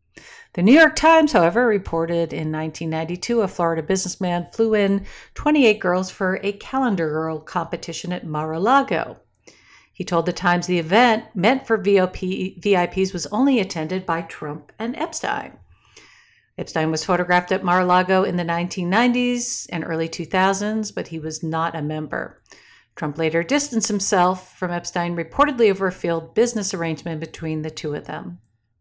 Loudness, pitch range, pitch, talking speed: -21 LUFS, 165-215 Hz, 180 Hz, 160 wpm